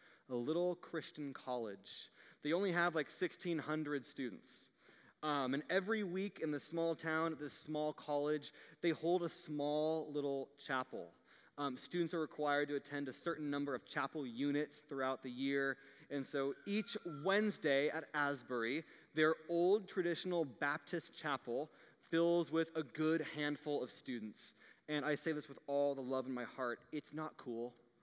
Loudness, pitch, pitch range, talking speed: -40 LUFS, 150 Hz, 140-165 Hz, 160 wpm